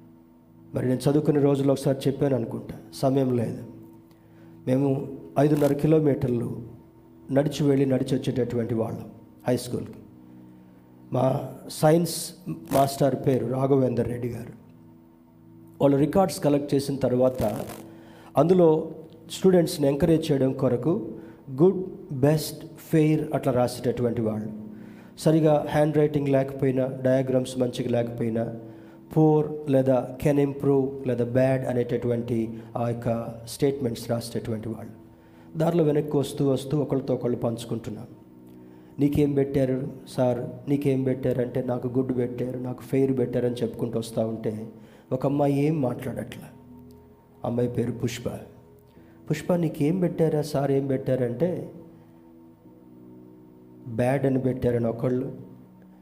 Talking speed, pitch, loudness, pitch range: 105 wpm, 125 Hz, -25 LUFS, 115-140 Hz